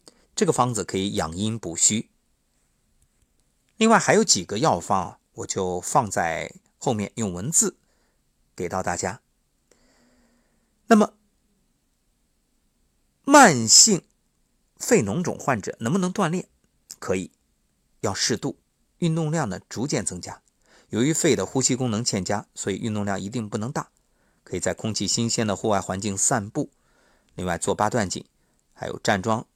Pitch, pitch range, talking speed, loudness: 115 Hz, 100-160 Hz, 205 characters per minute, -22 LUFS